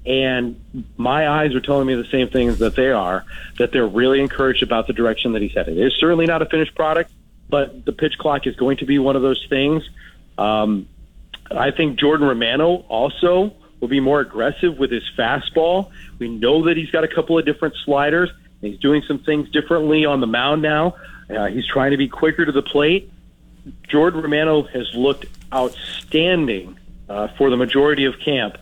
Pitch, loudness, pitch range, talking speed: 140 Hz, -18 LUFS, 125-155 Hz, 195 wpm